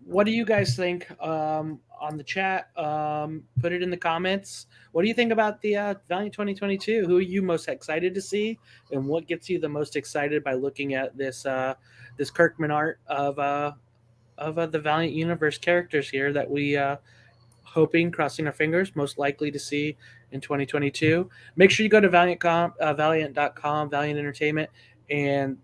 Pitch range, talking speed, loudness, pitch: 140-175 Hz, 185 wpm, -25 LUFS, 150 Hz